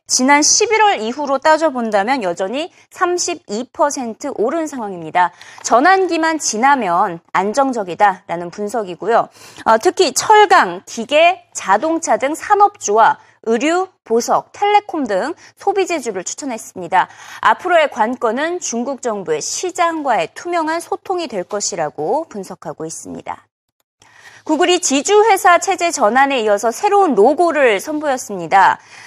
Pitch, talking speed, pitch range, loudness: 300 Hz, 280 characters per minute, 220-365 Hz, -15 LUFS